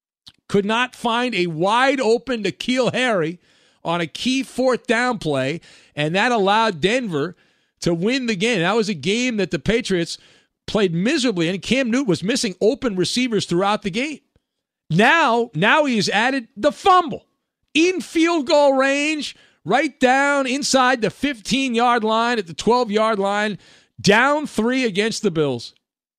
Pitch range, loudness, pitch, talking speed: 200-255 Hz, -19 LUFS, 230 Hz, 160 wpm